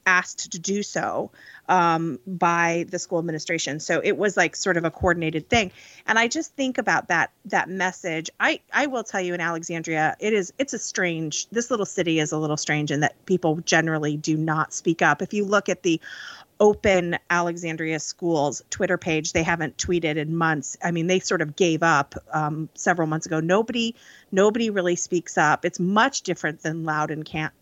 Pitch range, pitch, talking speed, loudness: 160-190 Hz, 170 Hz, 200 wpm, -23 LUFS